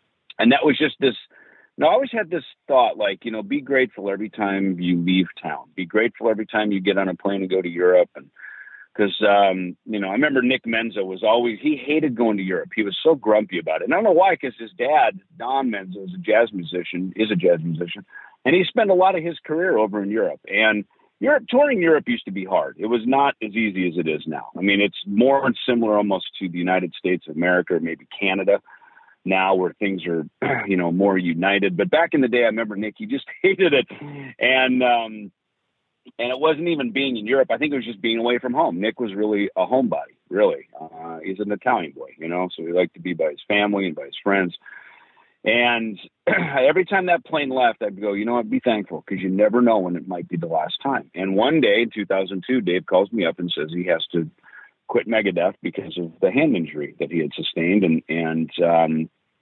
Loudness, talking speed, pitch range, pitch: -21 LUFS, 235 wpm, 95-130 Hz, 105 Hz